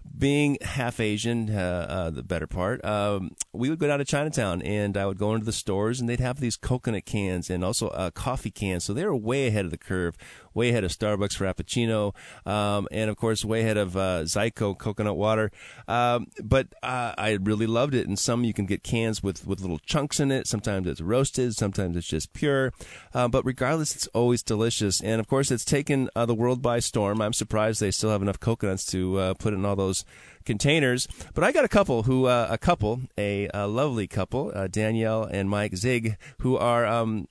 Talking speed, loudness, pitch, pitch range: 215 wpm, -26 LUFS, 110 Hz, 100-120 Hz